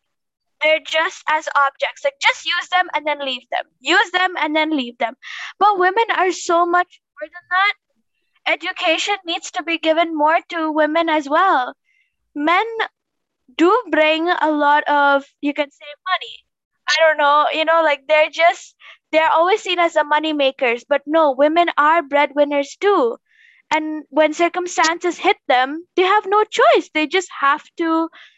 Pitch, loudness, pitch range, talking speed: 320 Hz, -17 LUFS, 295-360 Hz, 170 wpm